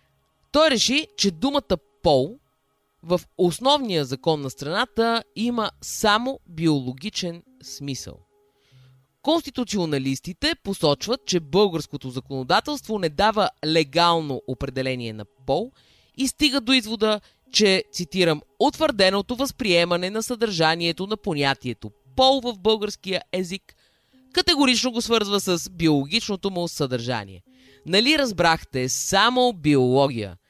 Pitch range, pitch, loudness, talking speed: 140-230 Hz, 180 Hz, -22 LUFS, 100 wpm